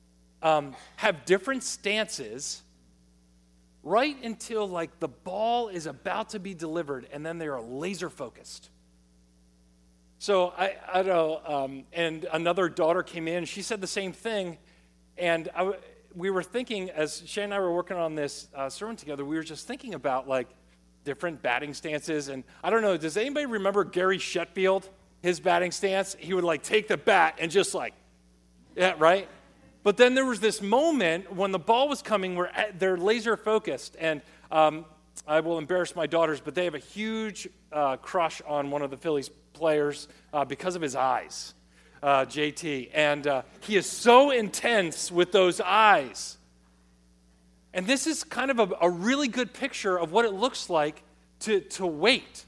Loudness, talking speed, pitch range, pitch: -27 LUFS, 175 wpm, 140-200 Hz, 170 Hz